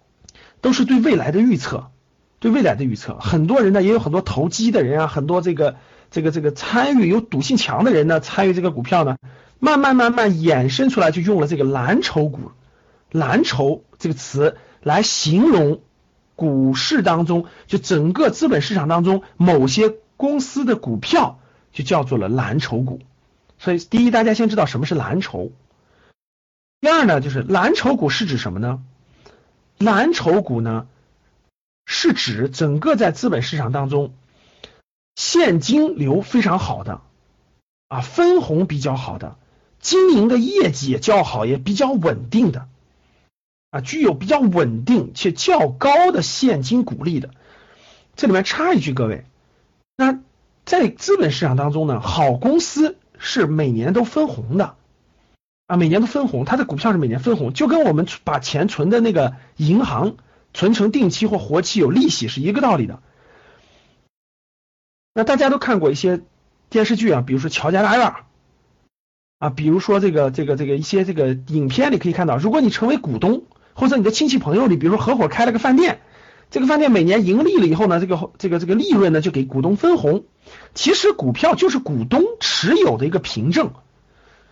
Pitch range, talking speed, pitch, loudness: 145-235 Hz, 260 characters per minute, 180 Hz, -18 LUFS